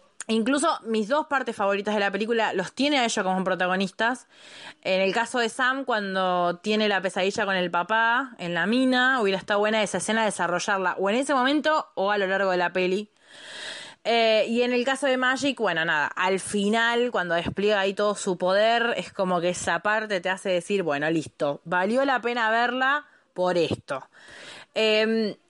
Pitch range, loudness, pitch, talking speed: 185-240 Hz, -24 LUFS, 210 Hz, 190 wpm